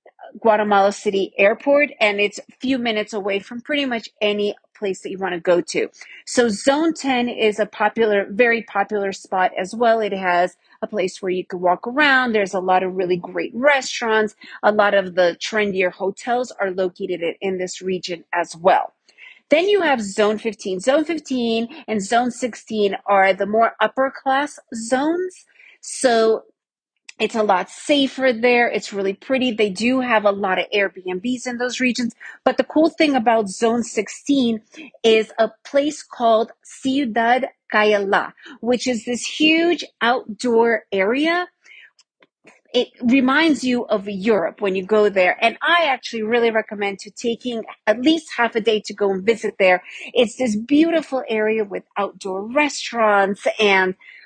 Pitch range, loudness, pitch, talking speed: 200-255 Hz, -19 LUFS, 225 Hz, 165 wpm